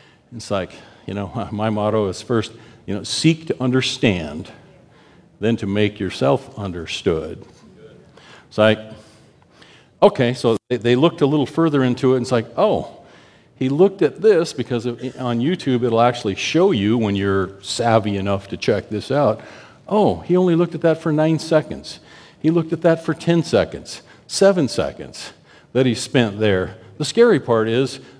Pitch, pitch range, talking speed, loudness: 125 Hz, 110-155 Hz, 165 wpm, -19 LUFS